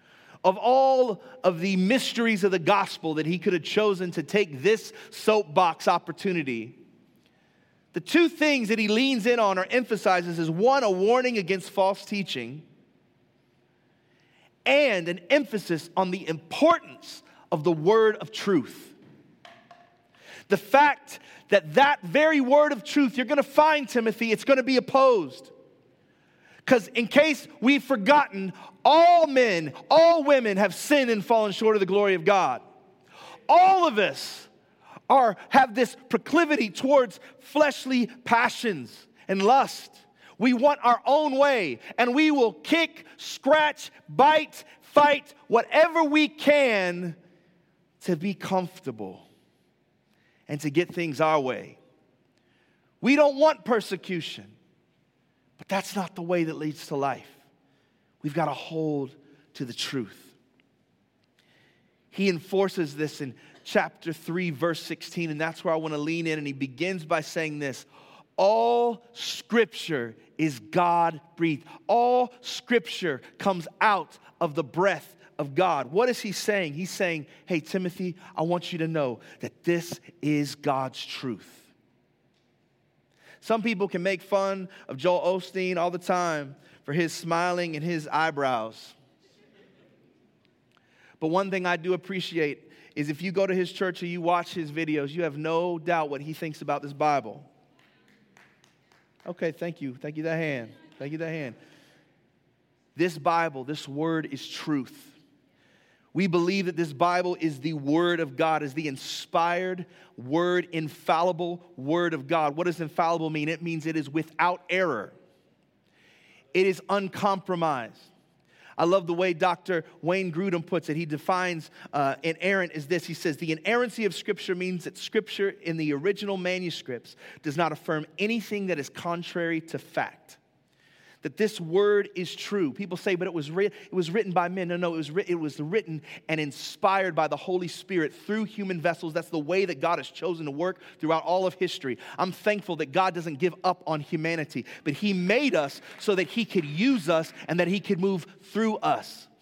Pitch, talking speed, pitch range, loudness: 180 Hz, 160 wpm, 160-210 Hz, -25 LUFS